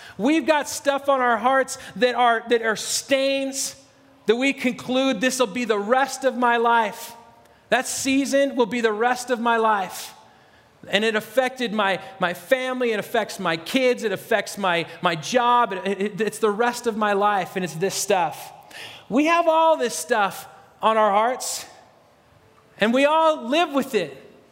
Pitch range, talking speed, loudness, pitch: 210-260 Hz, 175 wpm, -22 LUFS, 235 Hz